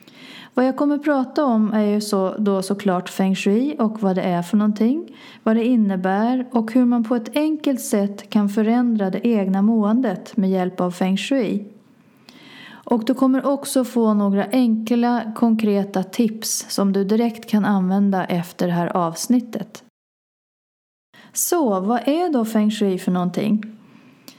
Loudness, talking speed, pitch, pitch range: -20 LUFS, 160 wpm, 220 Hz, 200-250 Hz